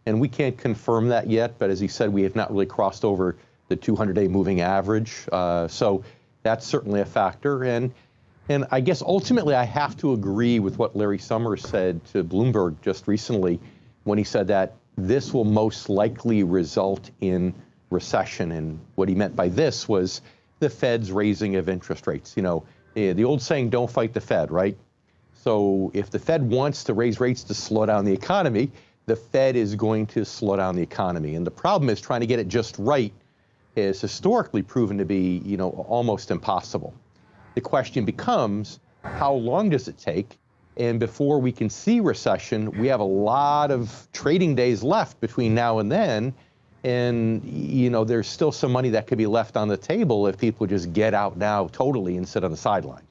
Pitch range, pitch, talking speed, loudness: 100-125 Hz, 110 Hz, 195 wpm, -24 LUFS